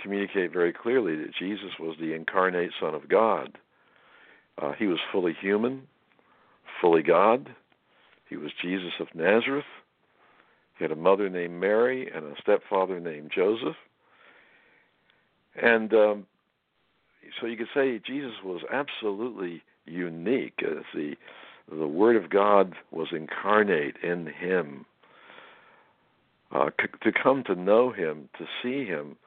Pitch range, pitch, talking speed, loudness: 90-145 Hz, 110 Hz, 130 wpm, -27 LUFS